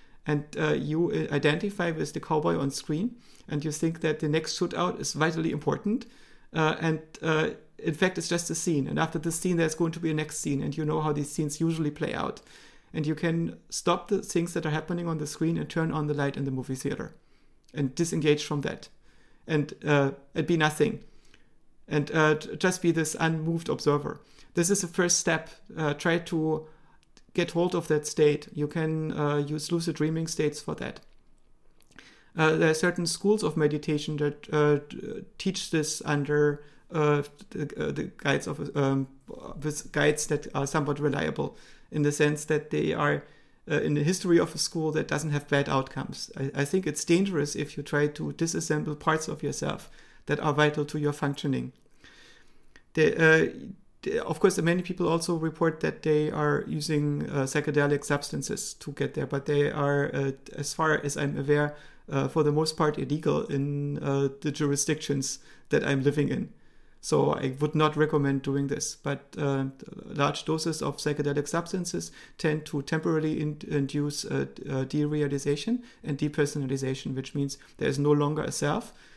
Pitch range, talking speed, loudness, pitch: 145-165 Hz, 185 wpm, -28 LUFS, 150 Hz